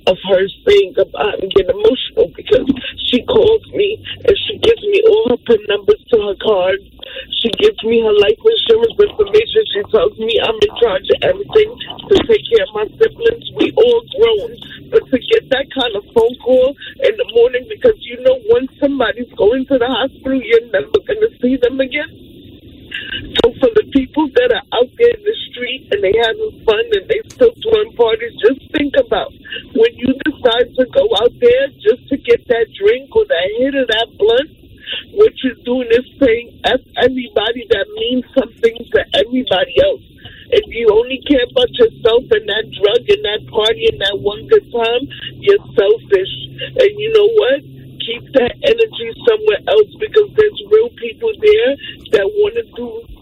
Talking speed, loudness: 185 wpm, -14 LUFS